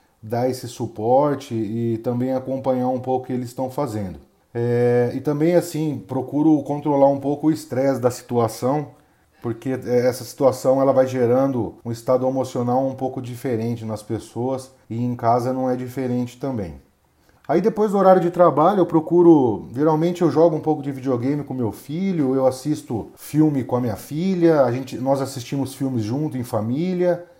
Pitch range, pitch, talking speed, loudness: 120-150 Hz, 130 Hz, 175 wpm, -21 LUFS